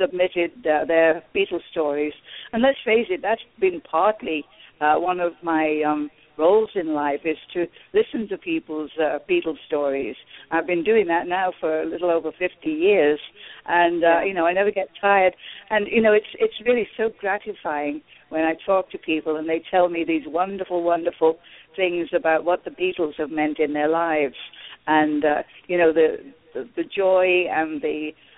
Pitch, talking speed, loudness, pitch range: 170 Hz, 185 wpm, -22 LUFS, 155-195 Hz